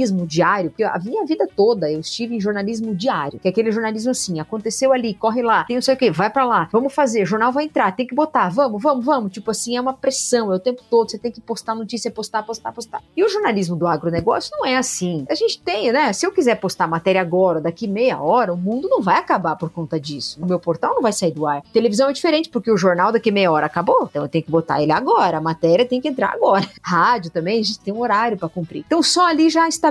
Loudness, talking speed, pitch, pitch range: -19 LUFS, 265 wpm, 225 Hz, 180-255 Hz